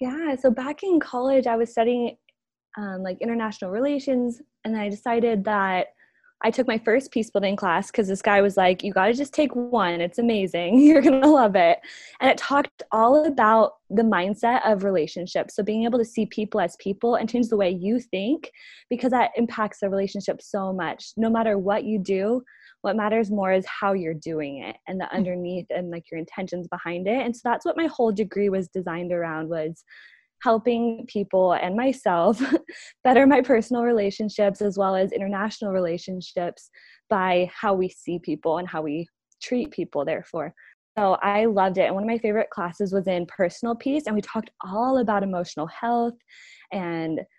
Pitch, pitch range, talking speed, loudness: 215 Hz, 190-245 Hz, 190 wpm, -23 LUFS